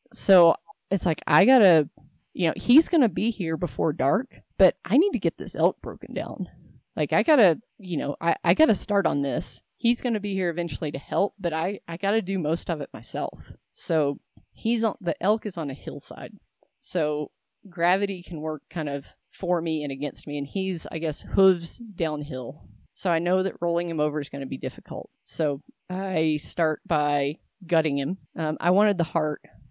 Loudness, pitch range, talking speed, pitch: -25 LUFS, 150-195 Hz, 195 wpm, 170 Hz